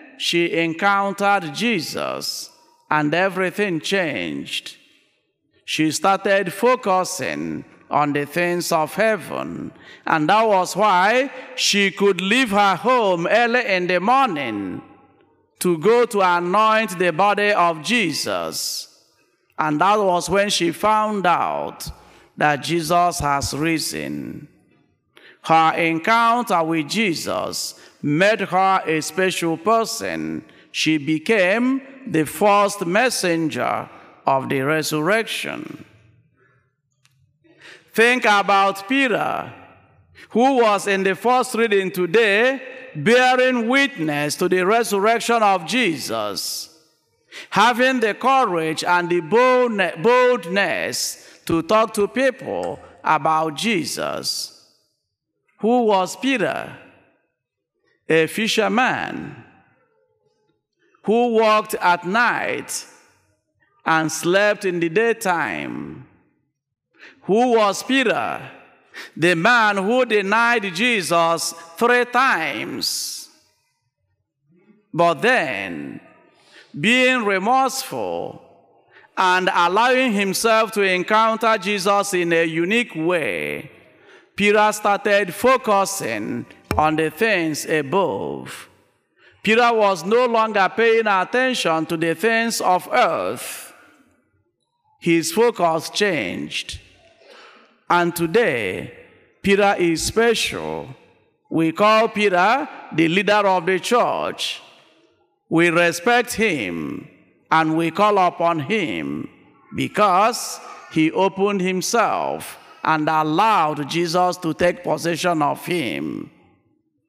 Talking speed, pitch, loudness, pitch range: 95 wpm, 200 Hz, -19 LUFS, 170-230 Hz